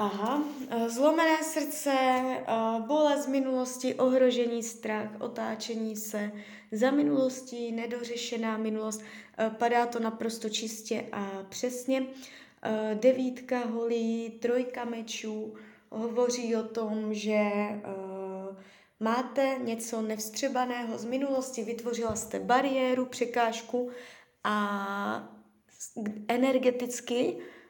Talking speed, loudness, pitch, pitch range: 85 wpm, -30 LUFS, 230 Hz, 220-255 Hz